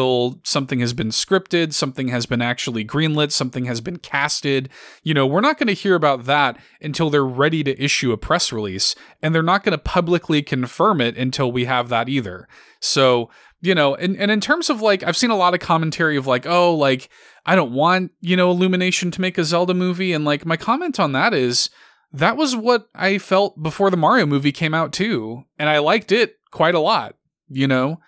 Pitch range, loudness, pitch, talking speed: 135-185 Hz, -19 LUFS, 155 Hz, 215 wpm